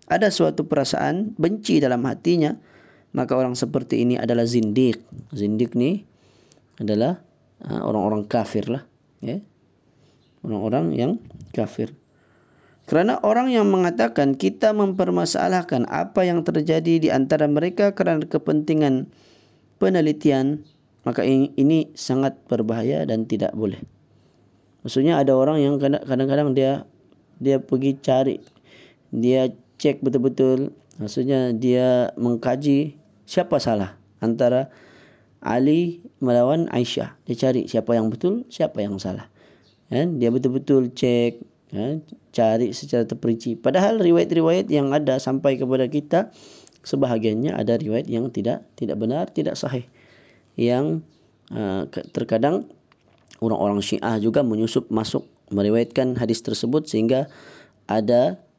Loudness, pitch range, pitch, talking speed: -22 LUFS, 115-150 Hz, 130 Hz, 110 wpm